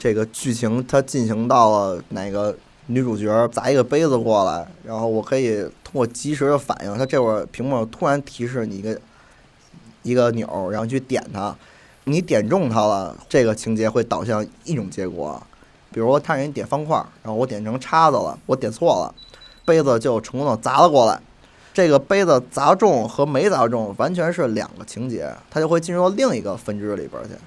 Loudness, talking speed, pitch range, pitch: -20 LUFS, 290 characters per minute, 110-140 Hz, 125 Hz